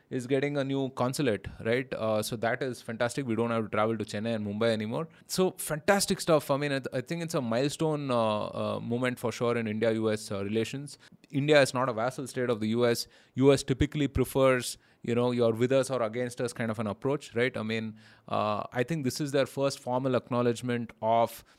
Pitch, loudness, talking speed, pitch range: 125 Hz, -29 LUFS, 220 wpm, 115-140 Hz